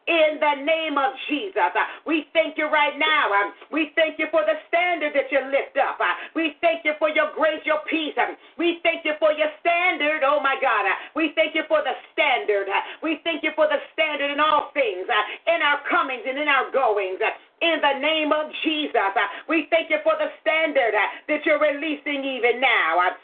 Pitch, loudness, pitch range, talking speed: 305 Hz, -22 LUFS, 285-320 Hz, 195 wpm